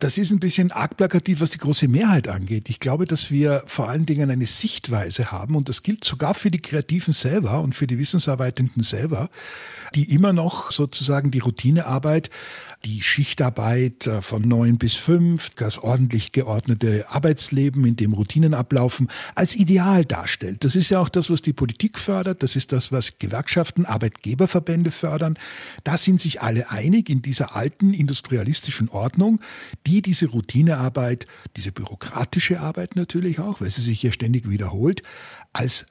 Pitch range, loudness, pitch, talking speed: 120-170 Hz, -21 LUFS, 140 Hz, 160 wpm